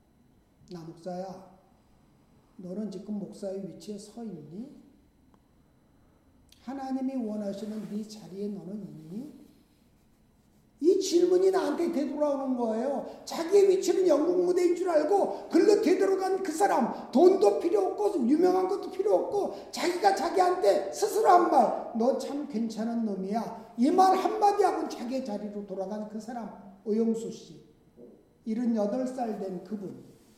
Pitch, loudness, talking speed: 255 Hz, -27 LUFS, 265 characters per minute